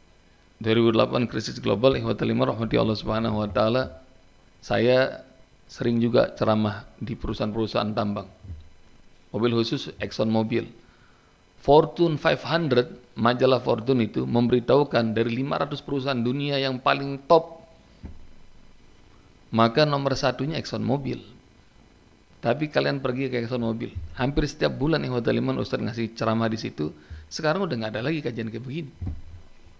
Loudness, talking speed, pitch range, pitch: -24 LUFS, 120 wpm, 105-135 Hz, 115 Hz